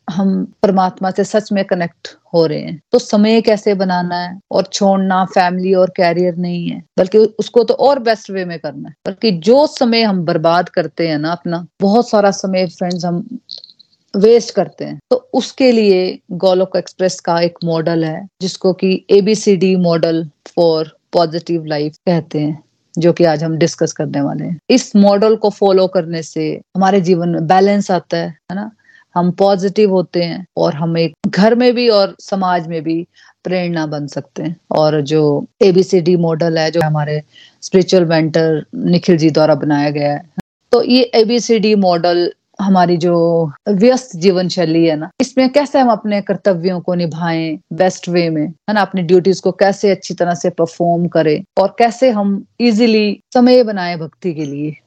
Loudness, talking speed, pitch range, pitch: -14 LUFS, 175 wpm, 170-205 Hz, 185 Hz